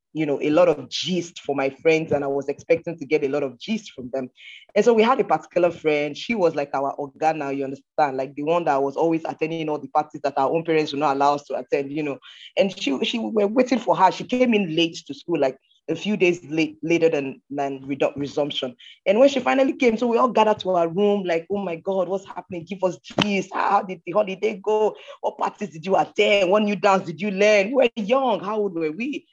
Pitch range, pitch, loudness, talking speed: 145-205 Hz, 170 Hz, -22 LUFS, 250 wpm